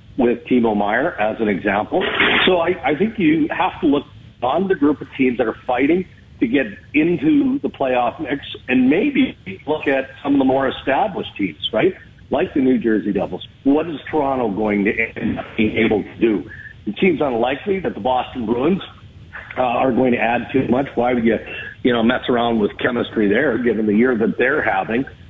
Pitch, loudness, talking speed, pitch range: 130 Hz, -18 LUFS, 200 wpm, 115-155 Hz